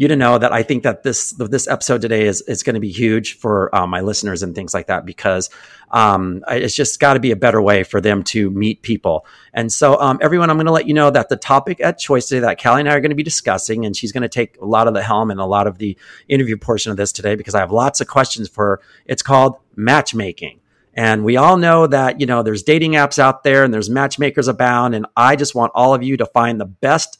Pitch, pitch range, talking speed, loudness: 120 Hz, 105-140 Hz, 270 wpm, -15 LUFS